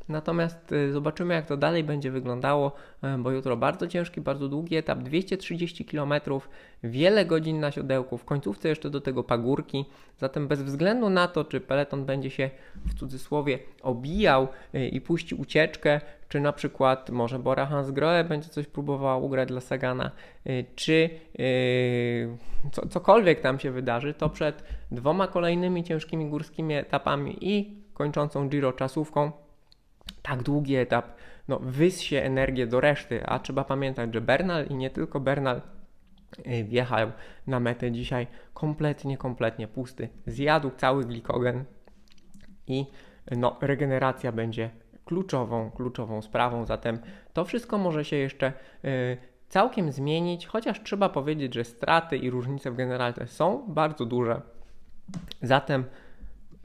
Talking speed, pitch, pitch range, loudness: 135 wpm, 140 Hz, 125-155 Hz, -28 LUFS